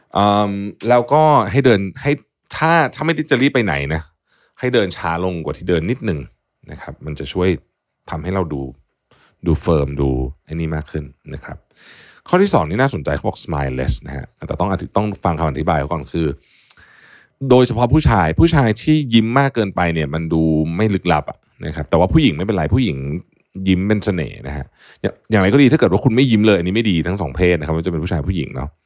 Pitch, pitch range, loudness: 90 Hz, 80-115 Hz, -17 LUFS